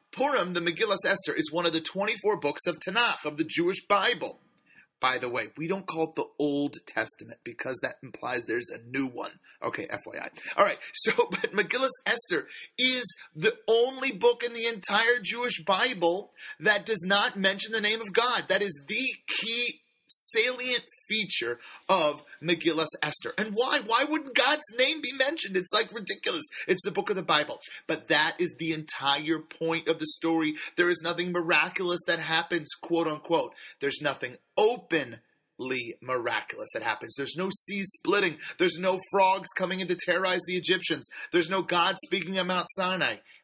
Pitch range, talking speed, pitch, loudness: 170-235 Hz, 175 wpm, 190 Hz, -27 LUFS